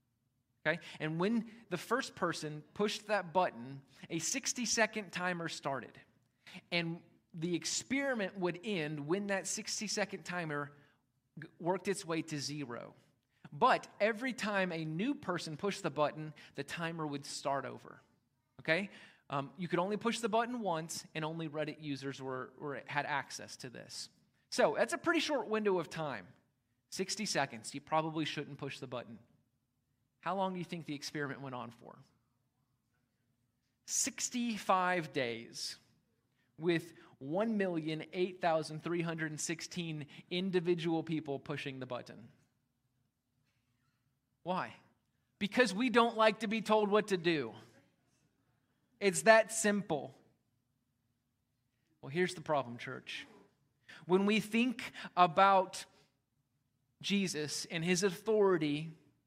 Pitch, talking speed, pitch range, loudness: 160 Hz, 125 wpm, 135-190 Hz, -35 LUFS